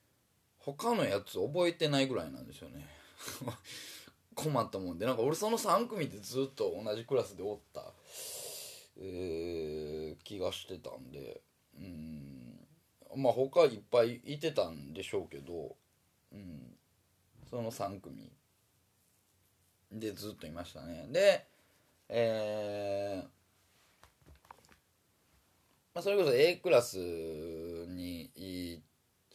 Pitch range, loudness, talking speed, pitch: 85-135 Hz, -35 LUFS, 205 characters per minute, 100 Hz